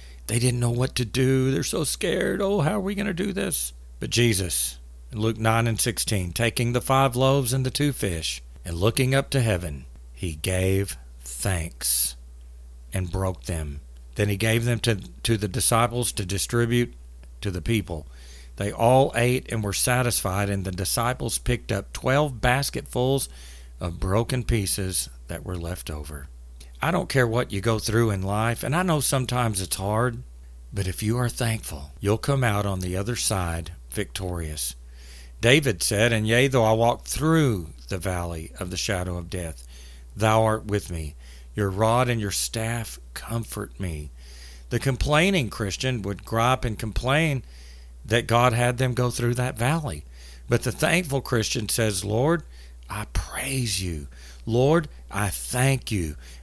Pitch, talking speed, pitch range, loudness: 105 Hz, 165 wpm, 75-120 Hz, -24 LUFS